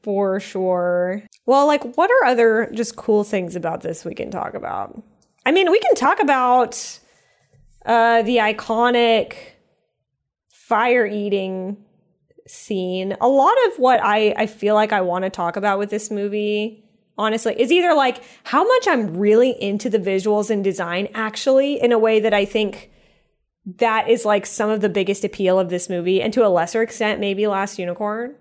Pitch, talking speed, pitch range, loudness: 215 Hz, 175 wpm, 200-235 Hz, -19 LUFS